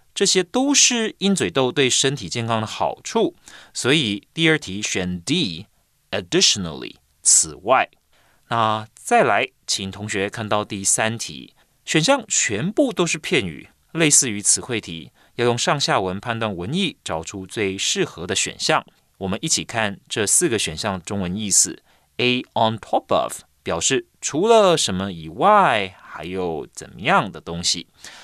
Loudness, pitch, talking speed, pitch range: -20 LUFS, 110 Hz, 245 characters per minute, 95-155 Hz